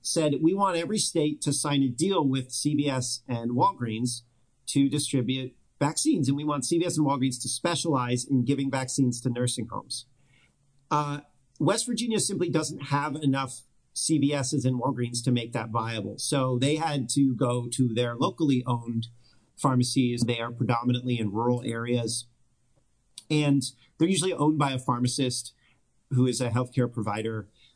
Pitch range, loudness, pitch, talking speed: 120-145 Hz, -27 LUFS, 130 Hz, 155 wpm